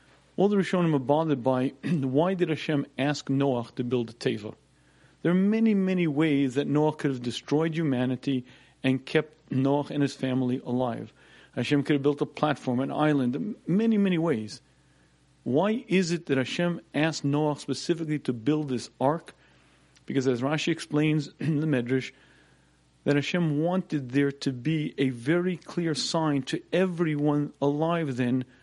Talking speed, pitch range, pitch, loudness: 160 wpm, 130-165 Hz, 145 Hz, -27 LUFS